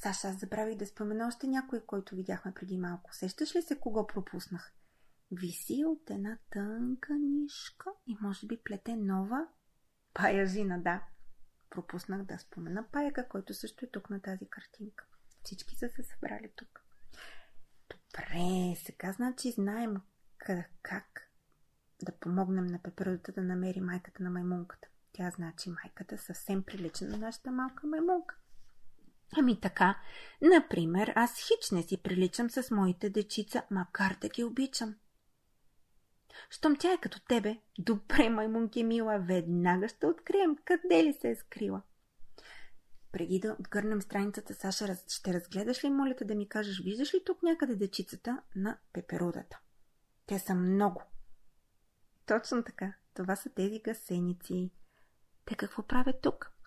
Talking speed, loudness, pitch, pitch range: 140 wpm, -34 LUFS, 205 Hz, 185-245 Hz